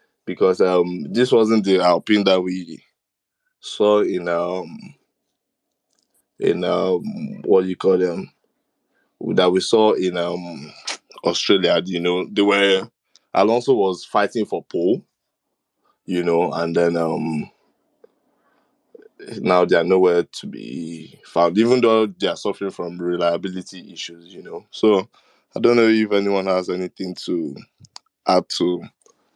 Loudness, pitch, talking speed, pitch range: -19 LUFS, 90 Hz, 135 wpm, 85-105 Hz